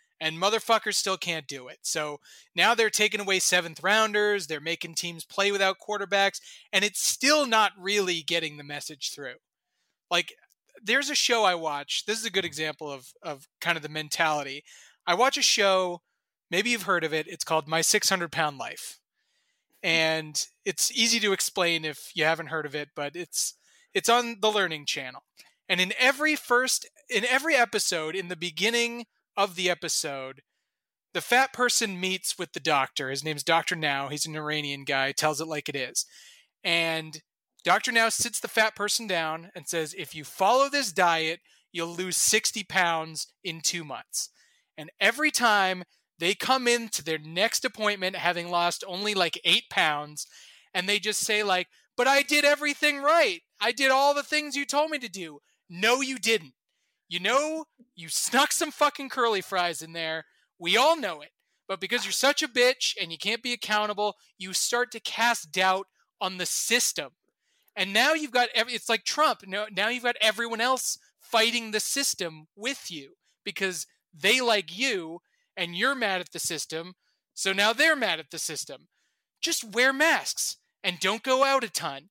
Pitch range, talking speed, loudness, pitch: 165-240 Hz, 185 wpm, -25 LUFS, 195 Hz